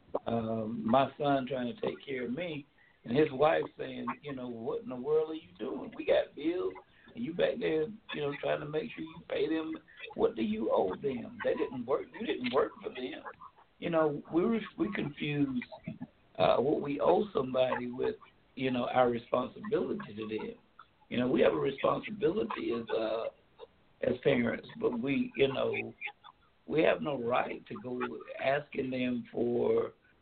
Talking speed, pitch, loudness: 185 wpm, 145 Hz, -33 LUFS